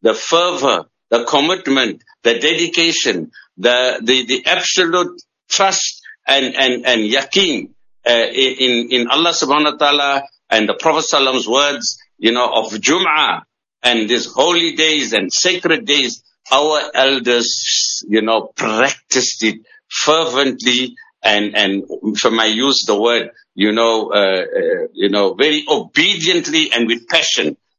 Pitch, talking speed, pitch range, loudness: 140 Hz, 135 wpm, 120-170 Hz, -14 LUFS